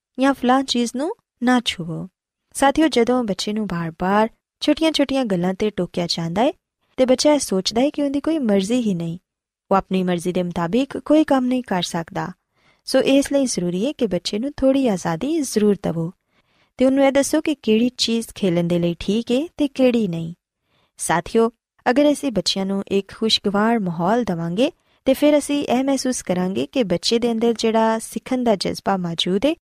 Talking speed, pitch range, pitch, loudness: 170 wpm, 190-270 Hz, 230 Hz, -20 LUFS